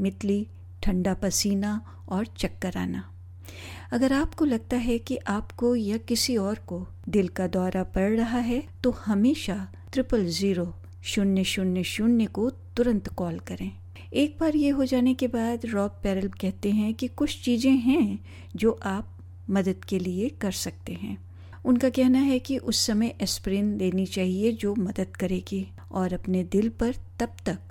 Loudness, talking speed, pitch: -27 LUFS, 160 wpm, 200 Hz